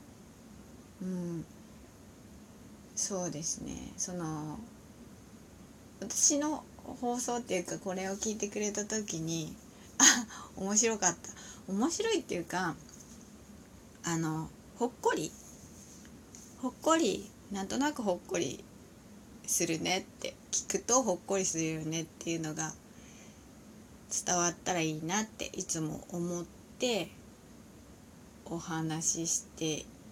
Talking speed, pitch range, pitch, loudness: 210 characters per minute, 165-235 Hz, 190 Hz, -33 LUFS